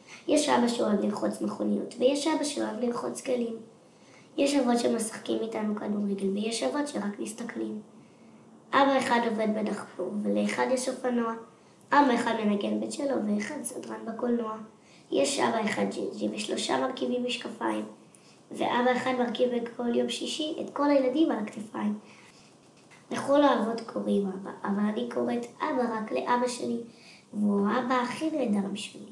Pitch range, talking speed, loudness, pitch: 205-250 Hz, 140 wpm, -29 LUFS, 230 Hz